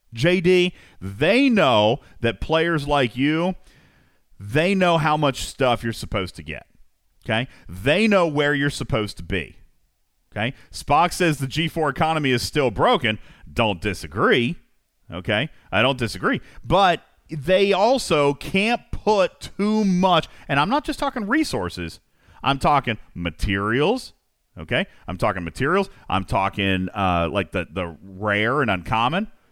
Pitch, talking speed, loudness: 135 Hz, 140 wpm, -21 LUFS